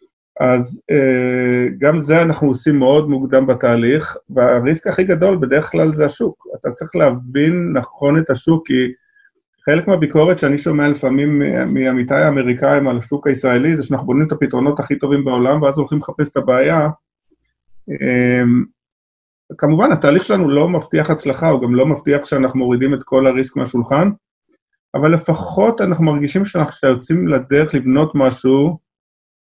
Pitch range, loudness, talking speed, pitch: 130-155 Hz, -15 LUFS, 145 wpm, 145 Hz